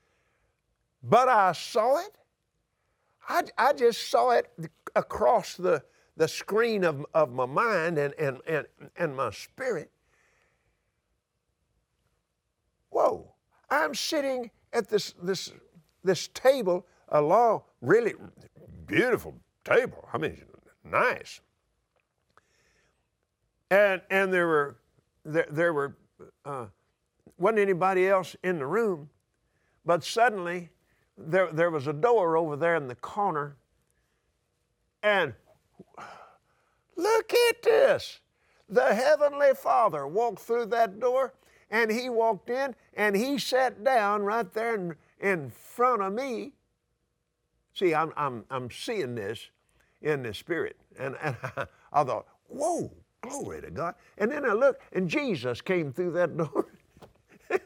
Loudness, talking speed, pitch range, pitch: -27 LUFS, 125 wpm, 165-250 Hz, 195 Hz